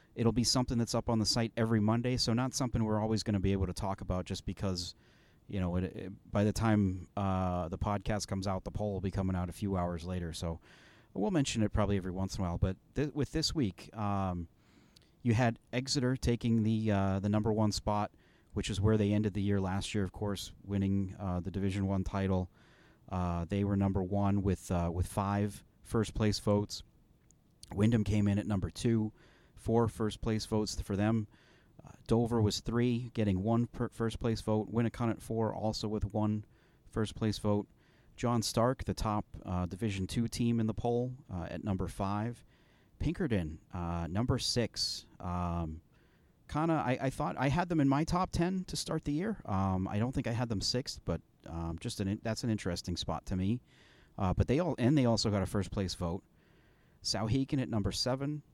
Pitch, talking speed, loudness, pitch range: 105 Hz, 210 wpm, -34 LUFS, 95-115 Hz